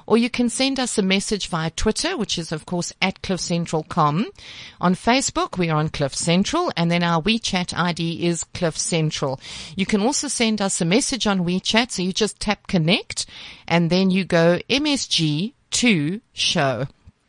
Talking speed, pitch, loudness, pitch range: 175 wpm, 185 Hz, -21 LUFS, 170-220 Hz